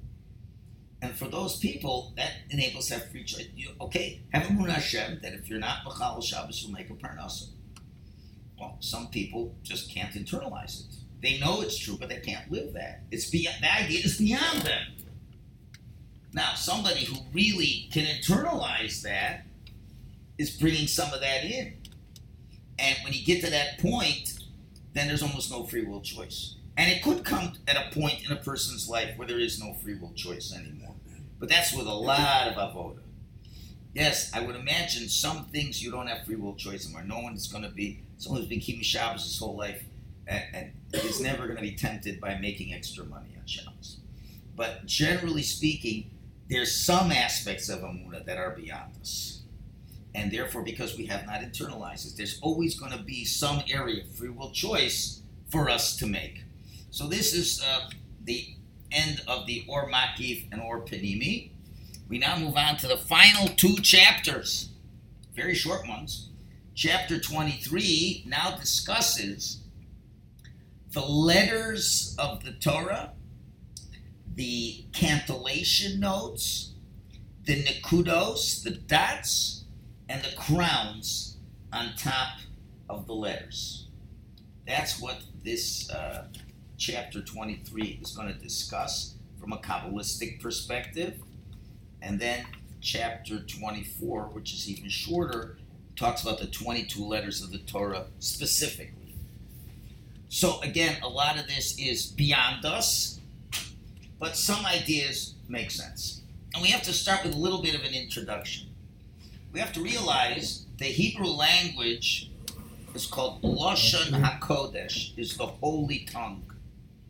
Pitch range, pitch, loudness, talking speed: 105-150 Hz, 120 Hz, -28 LUFS, 155 wpm